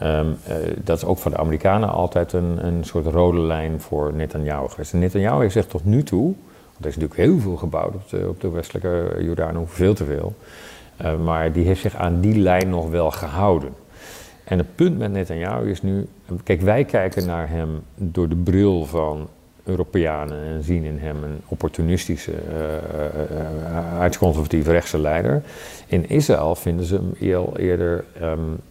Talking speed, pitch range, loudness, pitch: 185 wpm, 80-95 Hz, -21 LUFS, 85 Hz